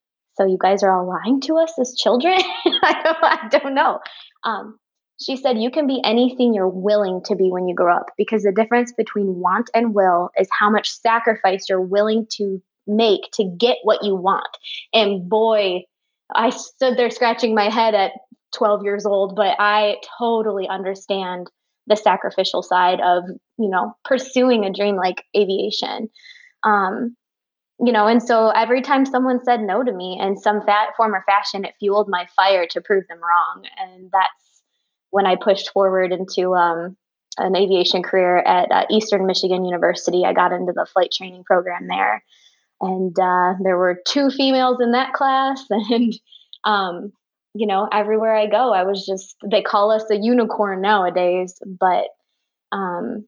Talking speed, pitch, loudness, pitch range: 175 wpm, 205 Hz, -18 LUFS, 190-235 Hz